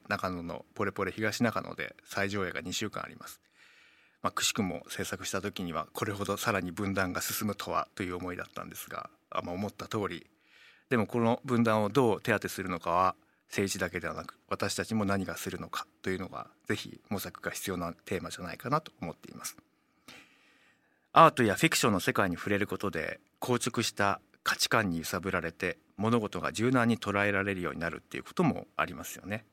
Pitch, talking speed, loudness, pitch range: 100 Hz, 400 characters per minute, -31 LUFS, 95-110 Hz